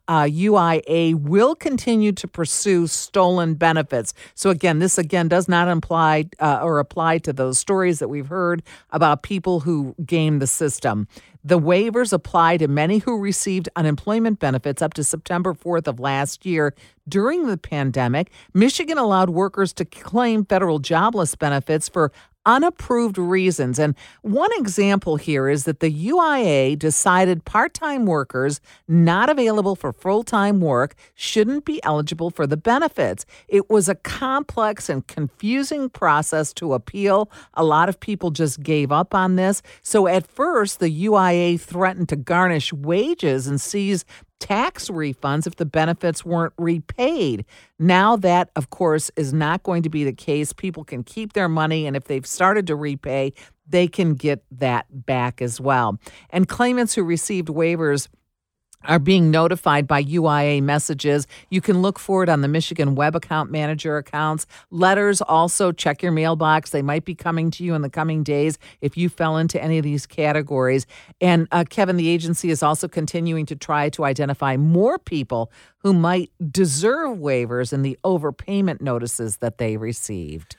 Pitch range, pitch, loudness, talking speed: 150-190 Hz, 165 Hz, -20 LUFS, 165 wpm